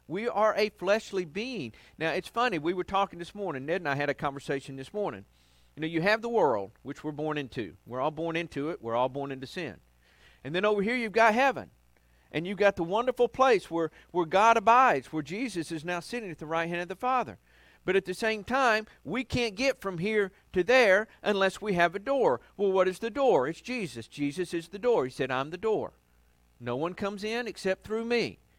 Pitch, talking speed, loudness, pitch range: 180 Hz, 230 wpm, -29 LUFS, 145-215 Hz